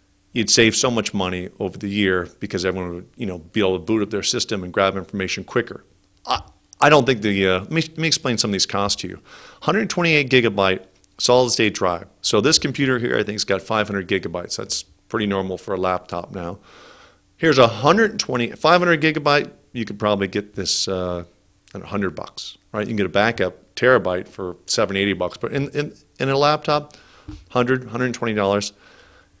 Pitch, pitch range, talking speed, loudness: 105 Hz, 95-125 Hz, 200 wpm, -20 LUFS